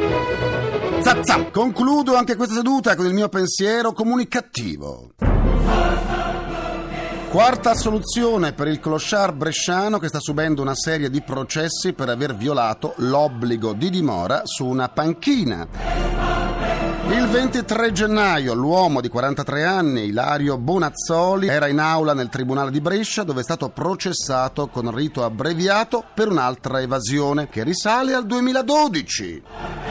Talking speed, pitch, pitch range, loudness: 120 wpm, 160 Hz, 135-215 Hz, -20 LUFS